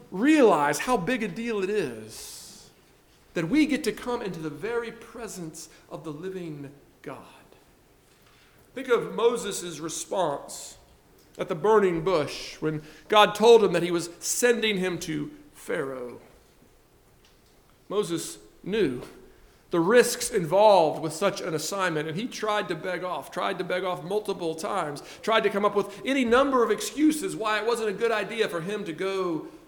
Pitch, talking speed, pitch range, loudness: 200 Hz, 160 wpm, 170-230 Hz, -25 LUFS